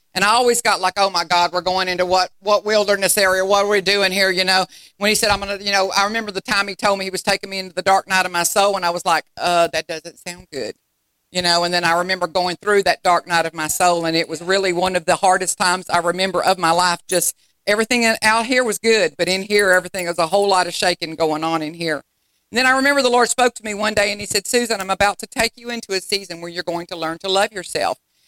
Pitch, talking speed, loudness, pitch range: 190 Hz, 285 wpm, -18 LUFS, 175-205 Hz